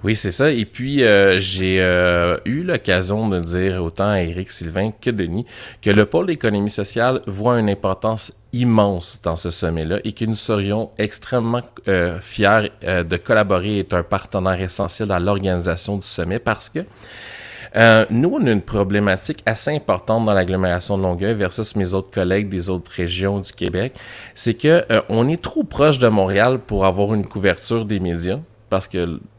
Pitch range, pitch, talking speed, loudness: 95-115 Hz, 100 Hz, 180 wpm, -18 LUFS